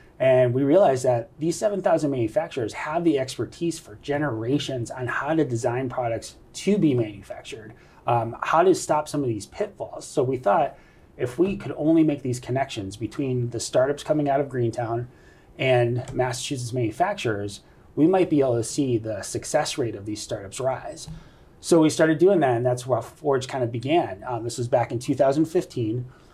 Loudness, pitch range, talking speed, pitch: -24 LUFS, 120-150 Hz, 180 wpm, 130 Hz